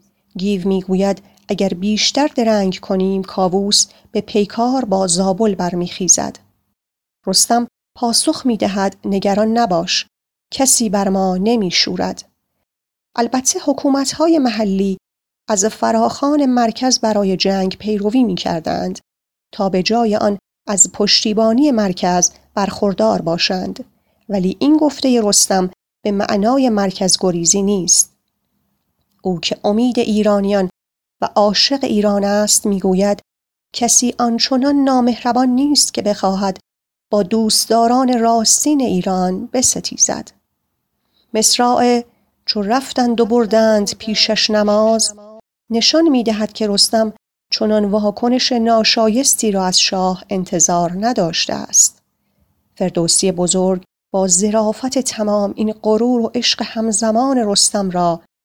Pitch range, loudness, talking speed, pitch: 195-235 Hz, -15 LUFS, 105 wpm, 215 Hz